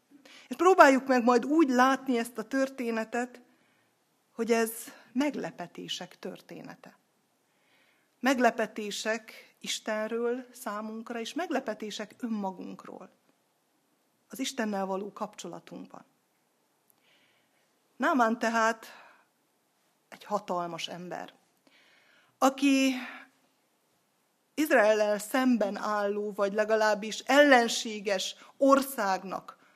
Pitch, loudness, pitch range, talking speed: 230 Hz, -28 LUFS, 210-265 Hz, 75 wpm